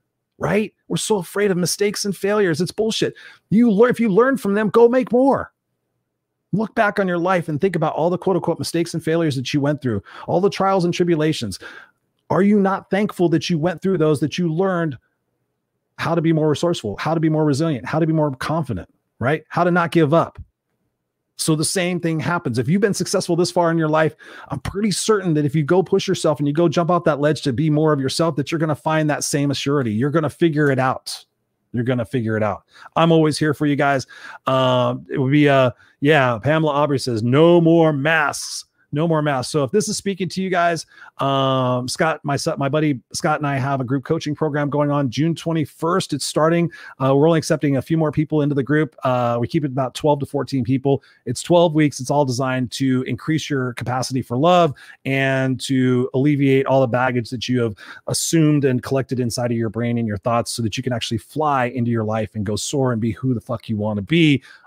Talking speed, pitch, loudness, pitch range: 235 wpm, 150 Hz, -19 LUFS, 130-170 Hz